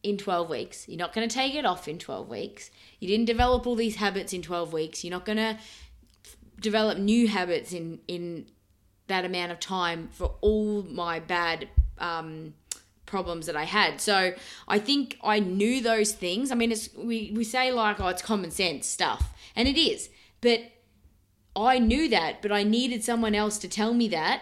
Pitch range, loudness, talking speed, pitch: 175-225 Hz, -27 LUFS, 195 wpm, 205 Hz